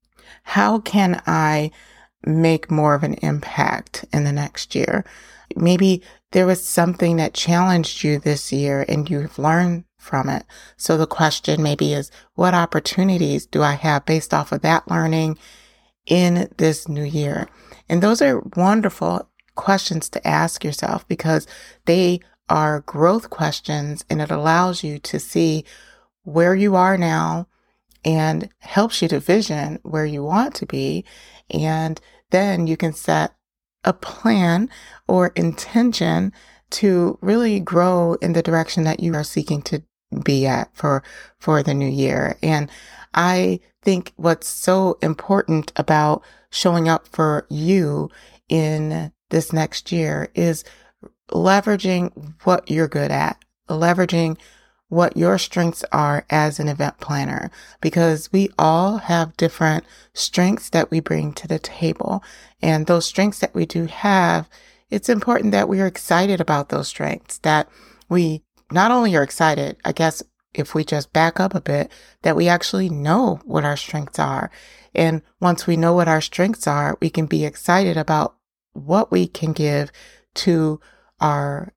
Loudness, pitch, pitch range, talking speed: -19 LUFS, 165 Hz, 150-180 Hz, 150 wpm